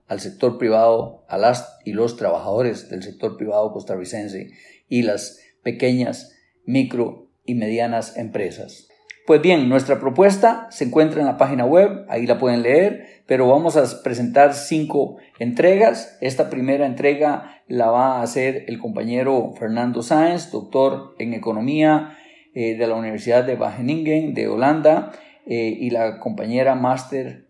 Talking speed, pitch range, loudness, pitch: 145 wpm, 115-155 Hz, -19 LUFS, 130 Hz